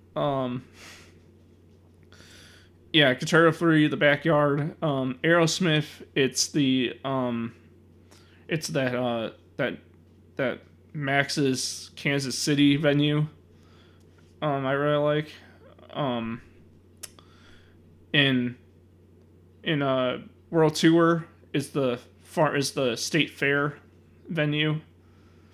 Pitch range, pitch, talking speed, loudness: 90-145 Hz, 125 Hz, 90 wpm, -25 LUFS